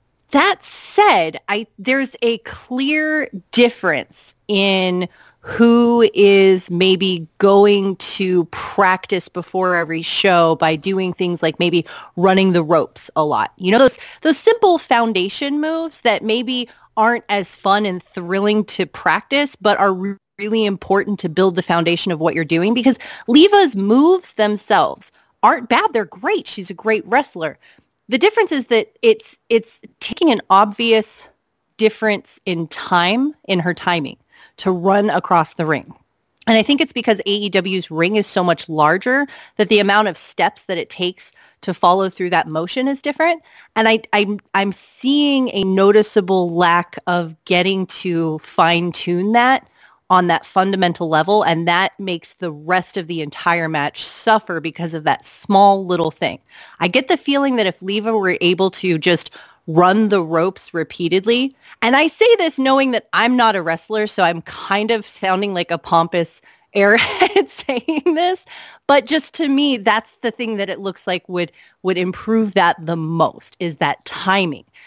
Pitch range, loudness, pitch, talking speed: 175-235 Hz, -16 LUFS, 195 Hz, 165 wpm